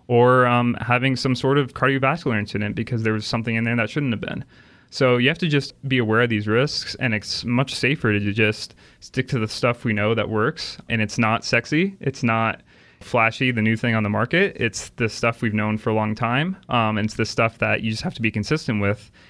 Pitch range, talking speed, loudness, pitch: 110-130 Hz, 240 wpm, -21 LUFS, 115 Hz